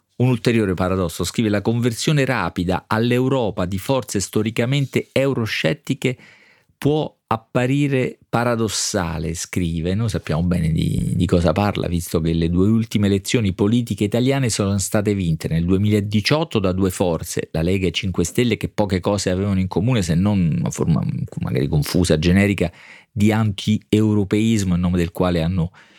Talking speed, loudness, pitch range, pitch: 150 wpm, -20 LUFS, 90-115 Hz, 105 Hz